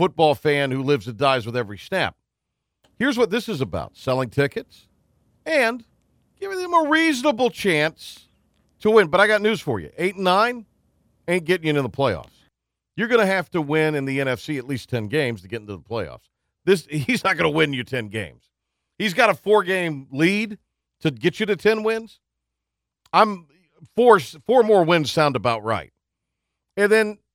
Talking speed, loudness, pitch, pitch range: 190 wpm, -21 LUFS, 160 Hz, 130-215 Hz